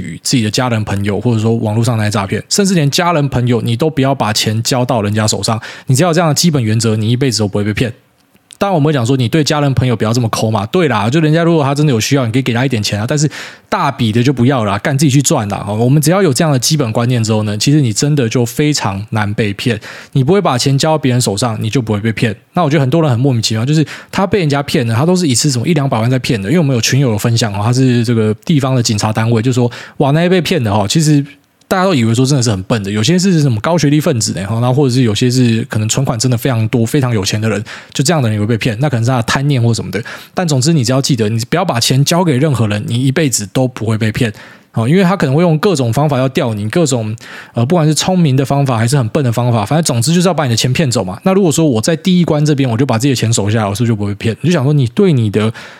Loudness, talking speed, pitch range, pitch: -13 LUFS, 430 characters per minute, 115-150 Hz, 130 Hz